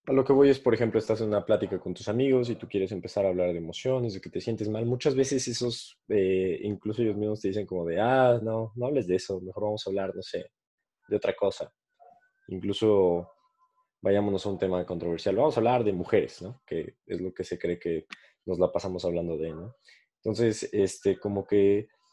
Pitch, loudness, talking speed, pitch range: 110 Hz, -28 LUFS, 220 wpm, 95-130 Hz